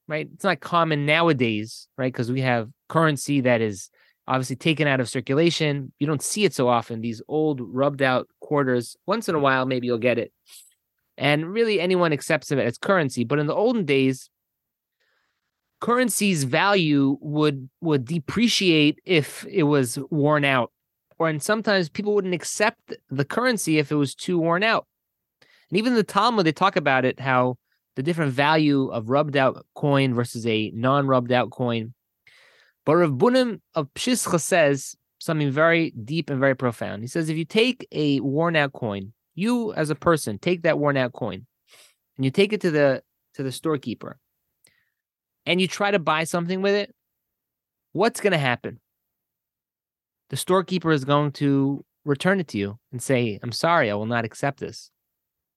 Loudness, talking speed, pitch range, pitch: -23 LUFS, 170 wpm, 130-170 Hz, 145 Hz